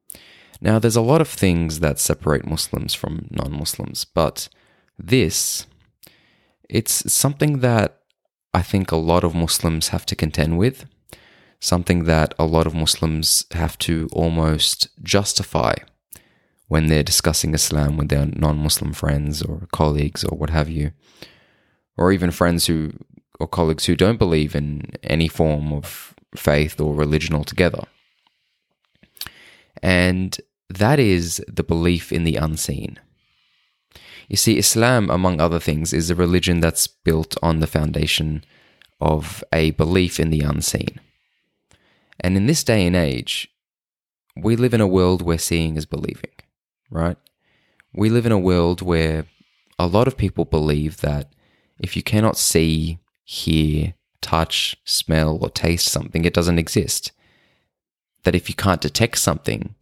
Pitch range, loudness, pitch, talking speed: 80-90 Hz, -19 LUFS, 85 Hz, 140 wpm